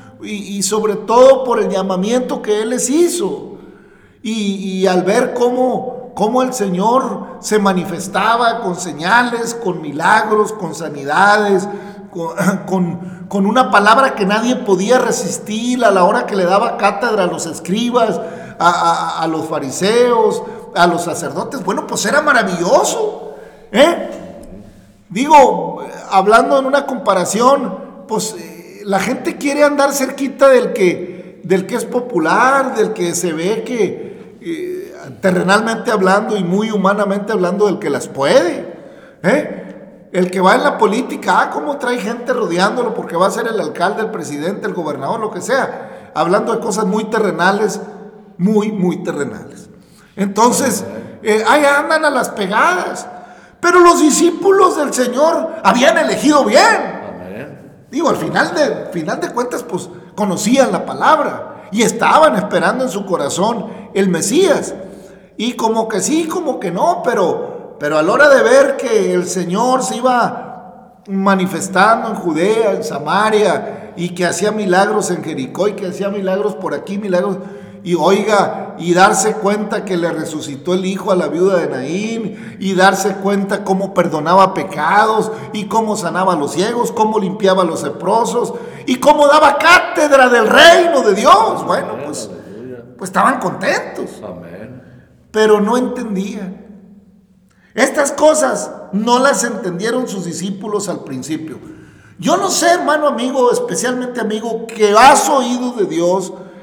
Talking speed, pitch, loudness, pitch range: 150 wpm, 210 Hz, -14 LUFS, 190-250 Hz